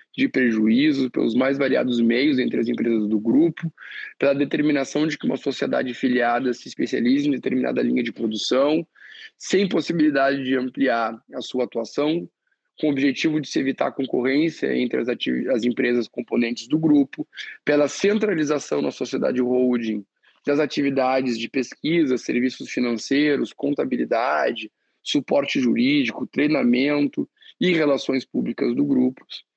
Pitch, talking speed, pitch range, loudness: 135 Hz, 135 wpm, 120-155 Hz, -22 LUFS